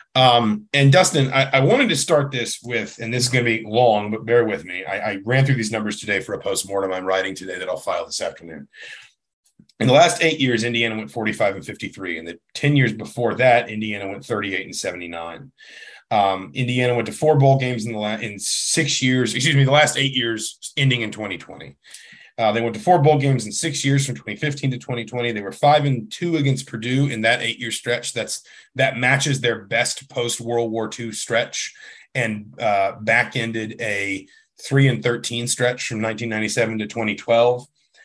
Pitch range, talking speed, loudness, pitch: 110-135 Hz, 205 wpm, -20 LUFS, 120 Hz